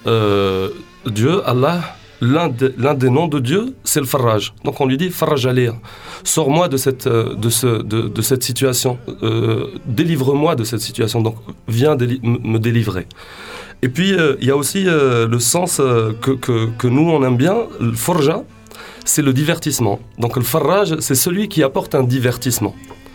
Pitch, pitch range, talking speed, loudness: 130 Hz, 115-145 Hz, 175 wpm, -16 LUFS